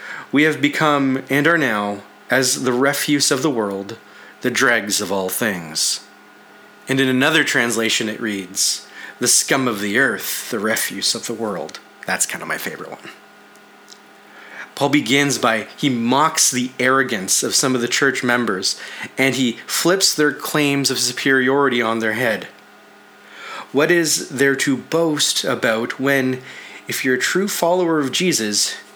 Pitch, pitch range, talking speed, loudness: 135 Hz, 115-145 Hz, 155 wpm, -18 LUFS